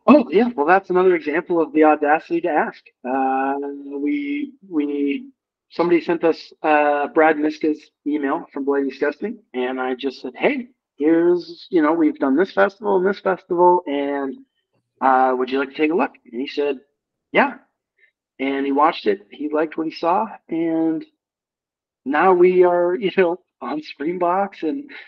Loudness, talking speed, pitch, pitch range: -20 LUFS, 170 wpm, 165 Hz, 140-200 Hz